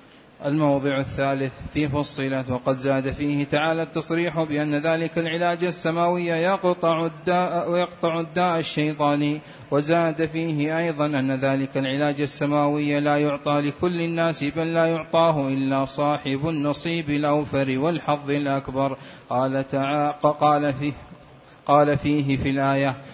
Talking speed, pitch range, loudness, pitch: 120 wpm, 140-165 Hz, -23 LUFS, 145 Hz